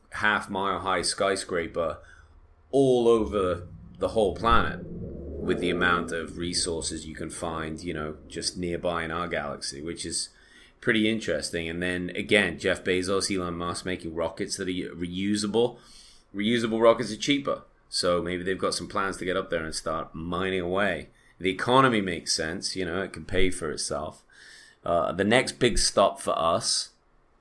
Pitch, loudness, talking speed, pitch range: 90 Hz, -27 LUFS, 165 wpm, 85-105 Hz